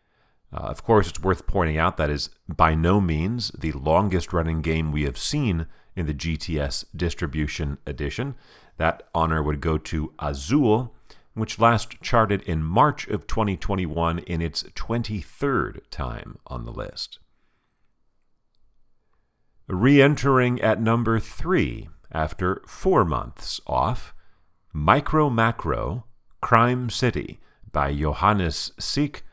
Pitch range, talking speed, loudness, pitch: 80-115 Hz, 125 wpm, -24 LUFS, 90 Hz